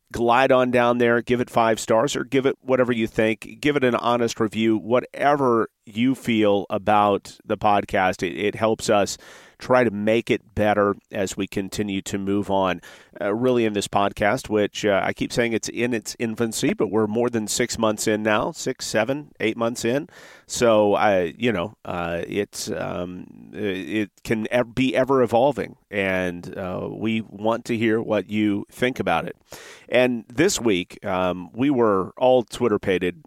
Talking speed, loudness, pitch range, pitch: 175 wpm, -22 LUFS, 105-120 Hz, 110 Hz